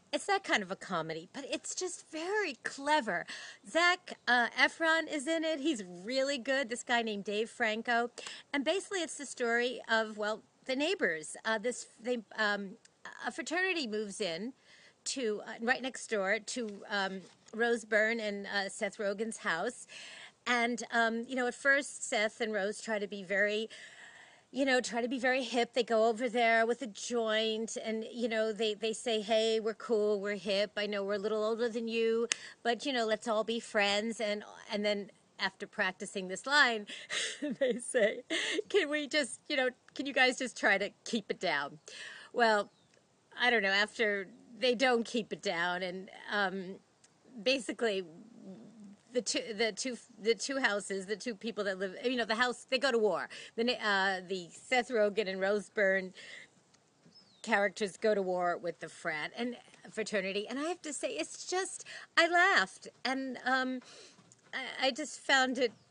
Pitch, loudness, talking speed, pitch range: 230 Hz, -33 LUFS, 180 wpm, 205-260 Hz